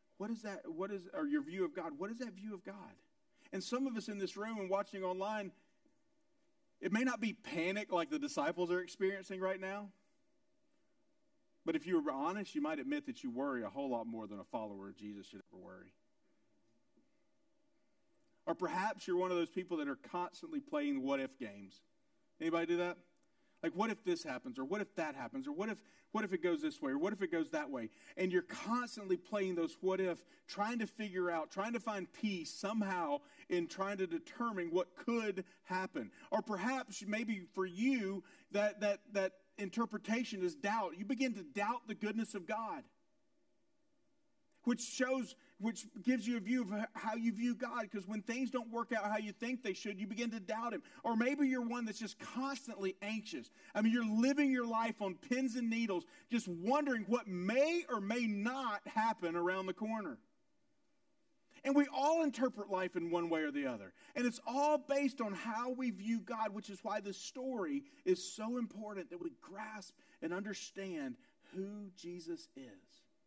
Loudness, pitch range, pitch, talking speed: -39 LUFS, 195-290 Hz, 230 Hz, 195 wpm